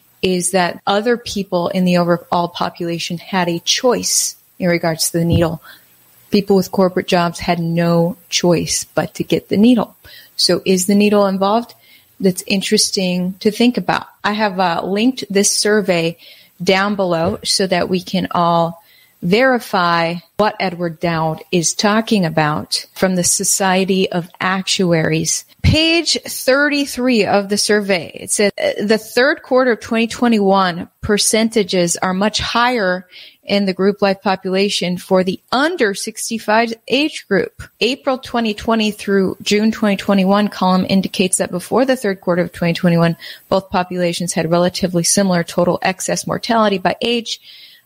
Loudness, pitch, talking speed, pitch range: -16 LUFS, 195 Hz, 145 wpm, 175-215 Hz